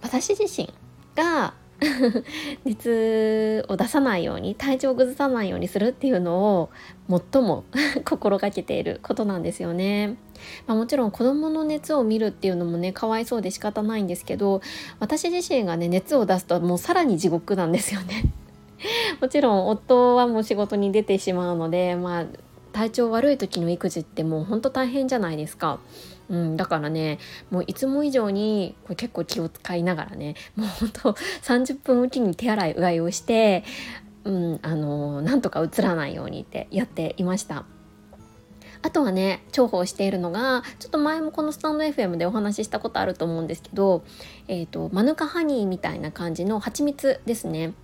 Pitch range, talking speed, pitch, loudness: 180-260 Hz, 335 characters per minute, 215 Hz, -24 LUFS